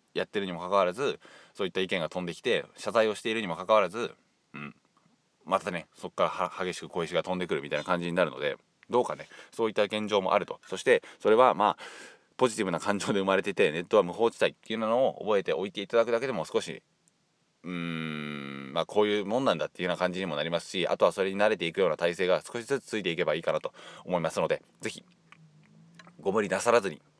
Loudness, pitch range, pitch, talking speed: -29 LUFS, 90-145 Hz, 105 Hz, 470 characters per minute